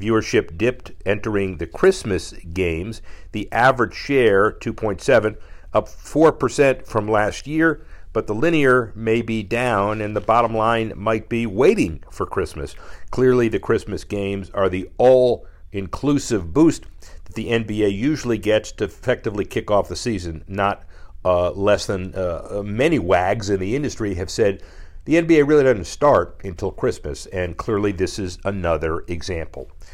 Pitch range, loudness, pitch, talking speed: 90-115 Hz, -20 LUFS, 105 Hz, 150 wpm